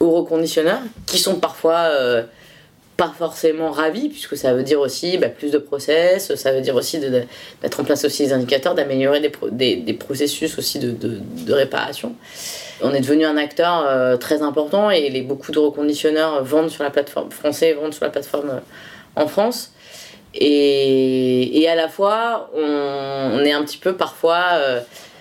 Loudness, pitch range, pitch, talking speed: -19 LUFS, 140-165 Hz, 150 Hz, 195 wpm